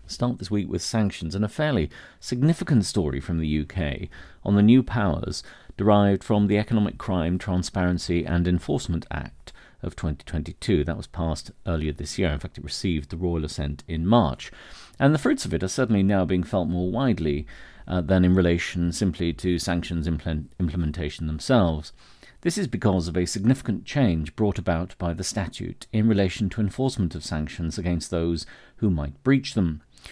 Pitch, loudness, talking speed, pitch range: 90 Hz, -25 LUFS, 175 wpm, 80-105 Hz